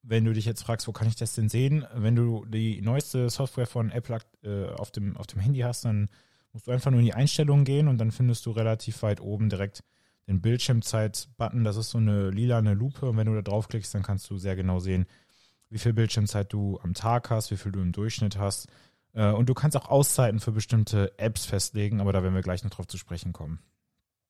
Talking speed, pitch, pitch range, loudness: 230 wpm, 110 Hz, 100-120 Hz, -27 LUFS